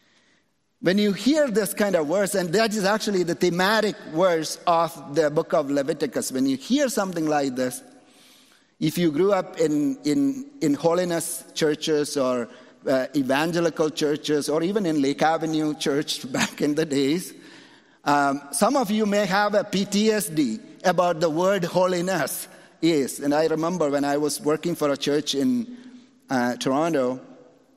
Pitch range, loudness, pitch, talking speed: 150-205 Hz, -23 LUFS, 170 Hz, 160 wpm